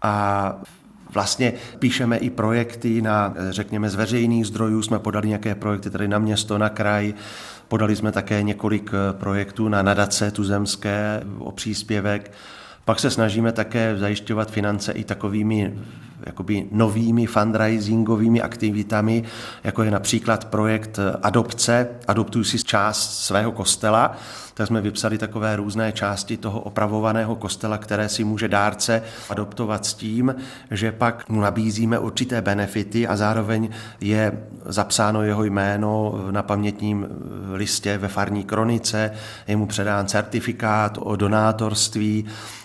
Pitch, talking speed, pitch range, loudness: 105 Hz, 125 wpm, 105-115 Hz, -22 LUFS